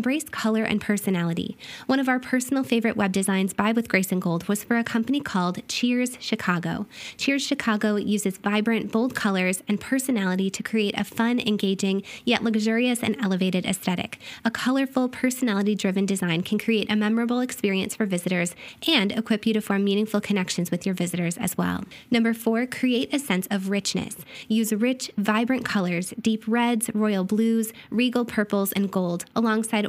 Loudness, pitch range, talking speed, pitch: -24 LUFS, 195-235 Hz, 170 wpm, 215 Hz